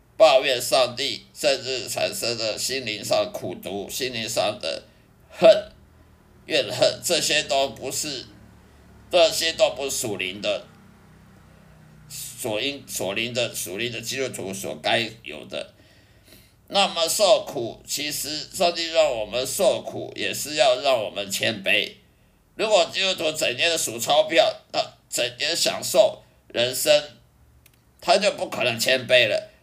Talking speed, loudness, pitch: 195 characters per minute, -22 LUFS, 150 Hz